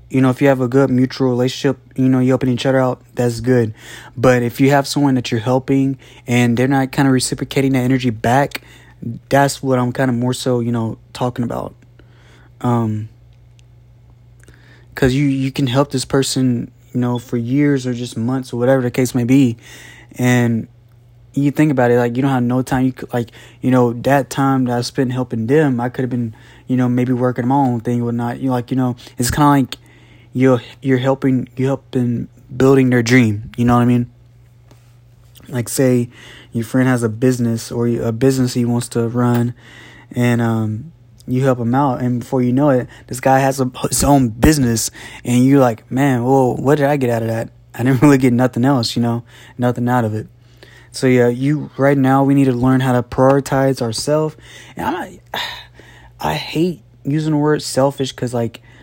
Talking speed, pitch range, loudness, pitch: 210 wpm, 120-135 Hz, -16 LUFS, 125 Hz